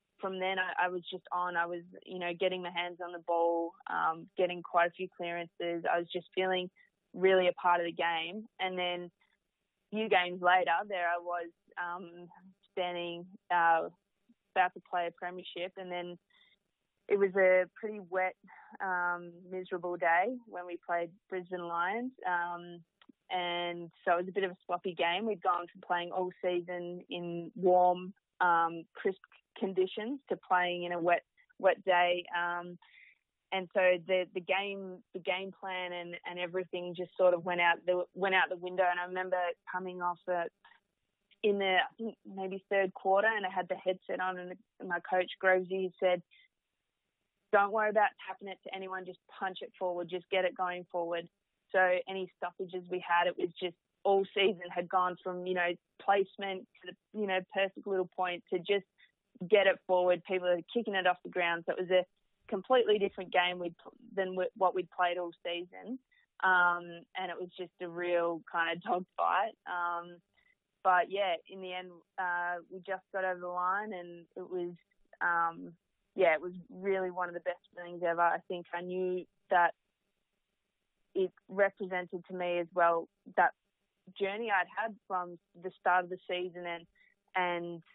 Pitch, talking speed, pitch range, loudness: 180 Hz, 185 wpm, 175-190 Hz, -33 LUFS